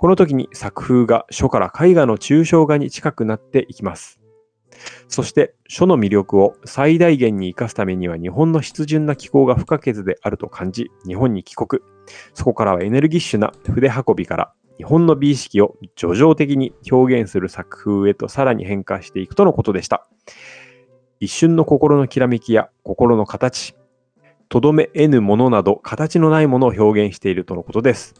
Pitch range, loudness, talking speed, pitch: 100-145 Hz, -16 LUFS, 345 characters per minute, 125 Hz